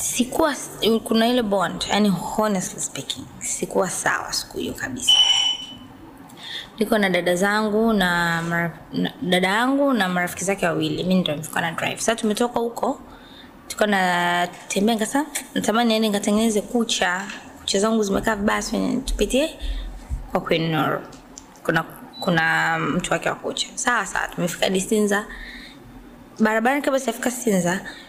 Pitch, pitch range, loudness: 215 Hz, 185-245 Hz, -21 LUFS